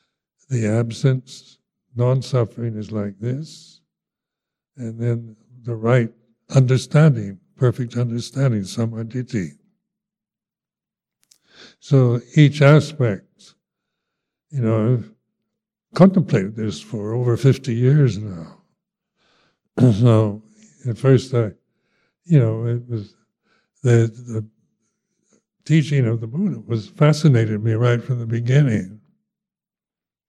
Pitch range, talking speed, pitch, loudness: 115-145 Hz, 95 wpm, 125 Hz, -19 LUFS